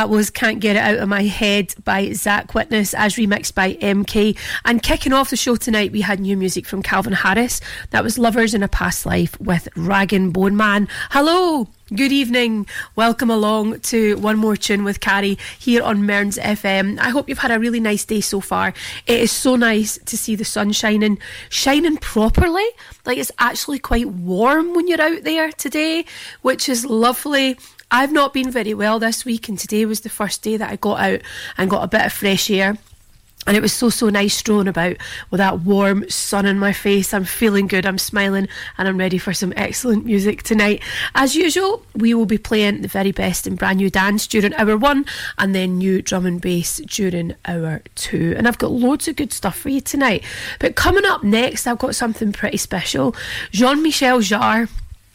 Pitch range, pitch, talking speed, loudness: 200-245 Hz, 215 Hz, 205 wpm, -17 LUFS